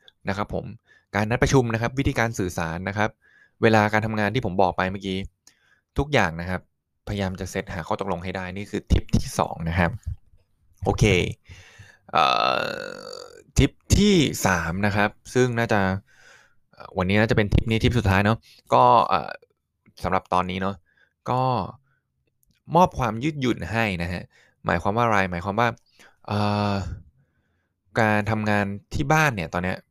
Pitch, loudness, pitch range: 100 Hz, -23 LUFS, 95-115 Hz